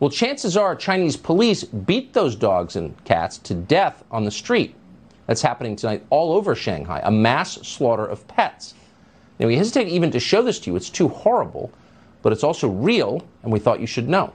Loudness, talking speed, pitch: -21 LUFS, 200 wpm, 125 Hz